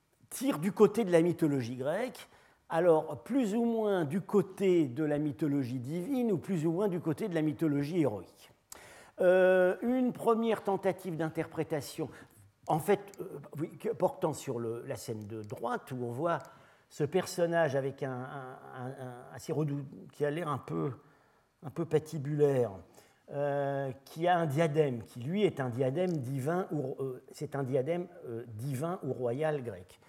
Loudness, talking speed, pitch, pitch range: -32 LUFS, 165 wpm, 155 Hz, 135-180 Hz